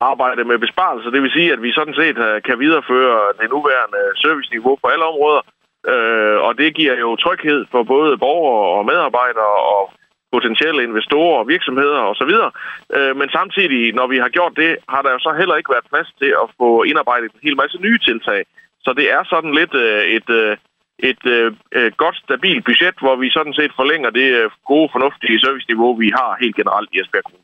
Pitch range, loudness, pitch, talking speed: 120-170 Hz, -15 LUFS, 140 Hz, 190 wpm